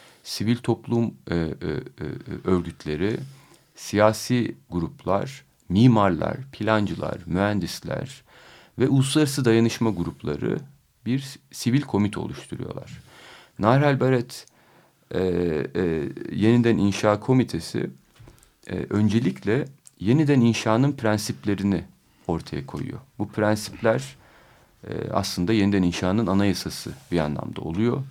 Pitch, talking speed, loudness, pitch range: 110 Hz, 90 wpm, -24 LUFS, 95-125 Hz